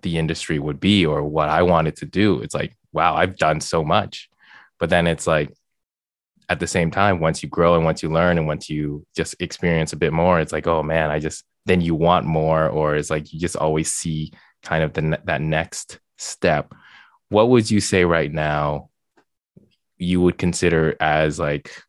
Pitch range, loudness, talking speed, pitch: 75-85 Hz, -20 LUFS, 205 wpm, 80 Hz